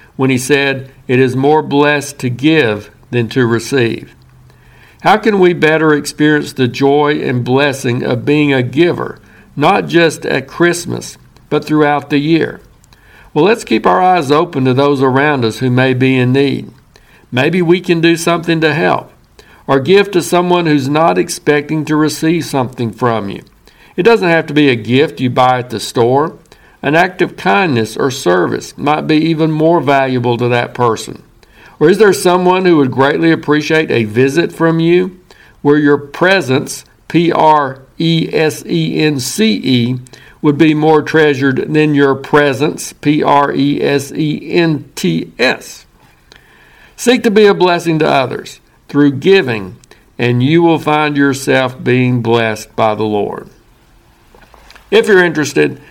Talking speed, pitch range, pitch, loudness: 165 wpm, 130-160 Hz, 145 Hz, -12 LUFS